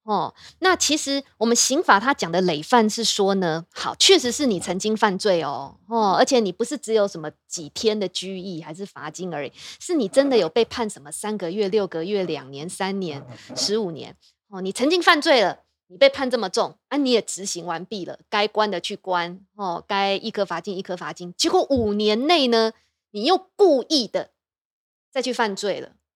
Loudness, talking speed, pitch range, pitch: -22 LUFS, 280 characters per minute, 180-245 Hz, 205 Hz